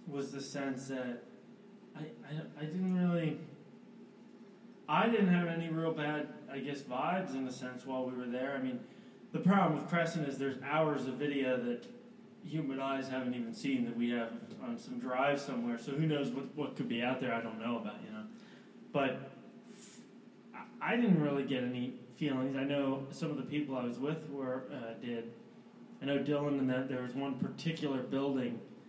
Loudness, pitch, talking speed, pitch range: -36 LUFS, 145 Hz, 195 wpm, 130-185 Hz